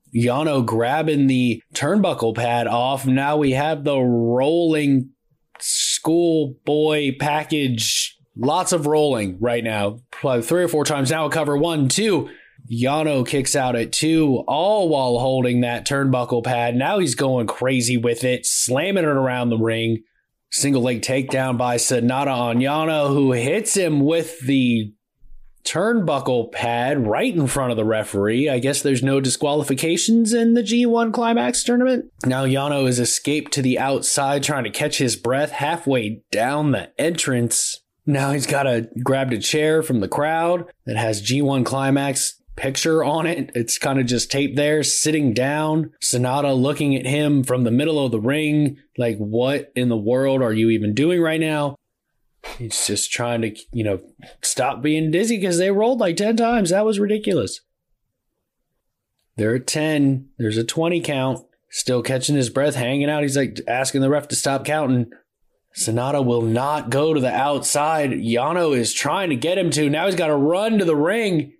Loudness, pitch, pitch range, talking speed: -20 LUFS, 135 Hz, 125-150 Hz, 170 wpm